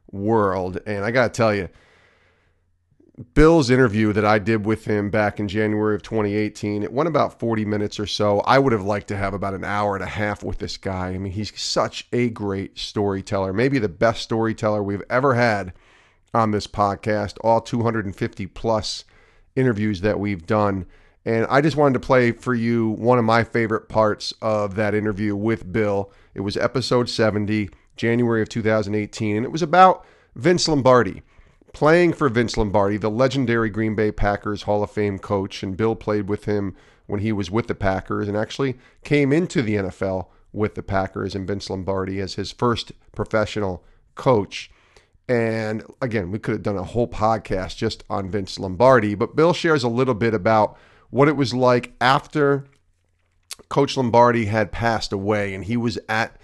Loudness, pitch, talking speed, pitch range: -21 LUFS, 110 Hz, 180 wpm, 100-120 Hz